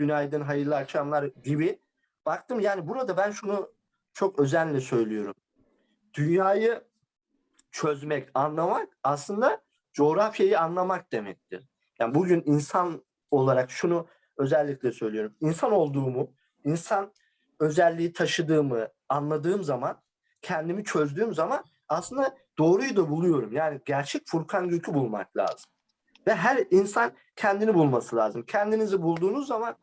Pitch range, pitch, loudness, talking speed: 145-205 Hz, 170 Hz, -27 LUFS, 110 wpm